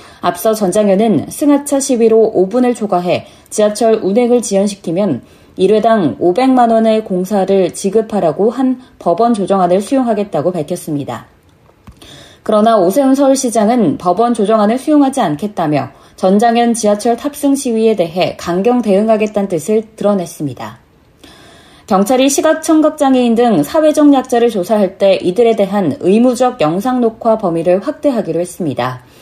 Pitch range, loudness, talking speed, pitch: 185-245 Hz, -13 LUFS, 325 characters per minute, 220 Hz